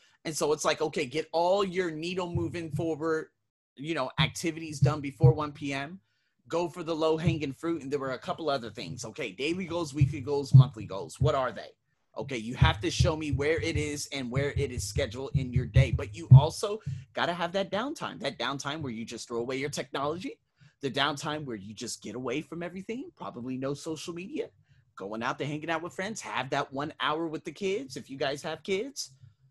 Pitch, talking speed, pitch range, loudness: 150 Hz, 215 wpm, 135-165 Hz, -30 LUFS